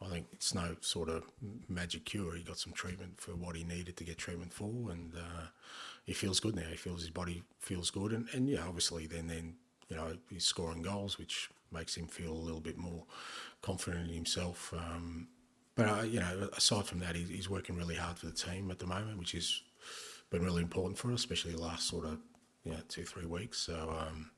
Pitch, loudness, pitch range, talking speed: 85 Hz, -39 LUFS, 85-95 Hz, 225 wpm